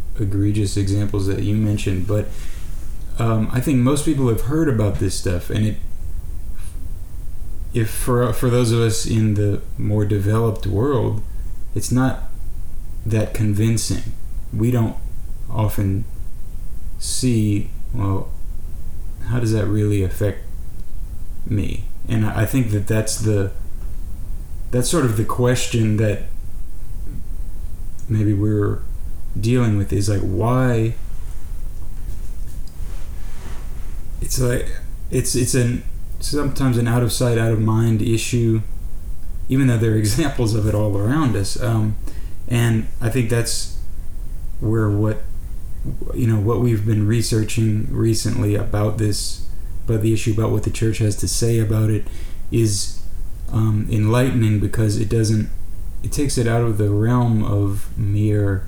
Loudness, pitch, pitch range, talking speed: -20 LUFS, 105 Hz, 90-115 Hz, 130 wpm